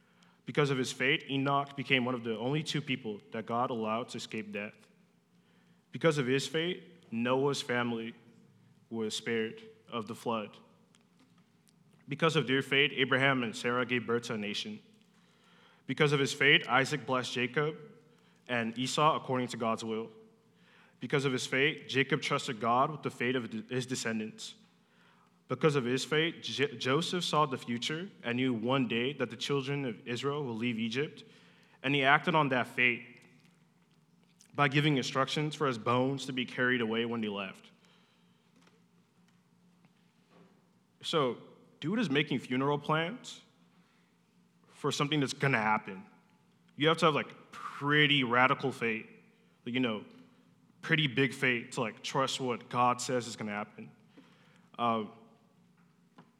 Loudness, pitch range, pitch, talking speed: -31 LUFS, 120-155 Hz, 135 Hz, 155 wpm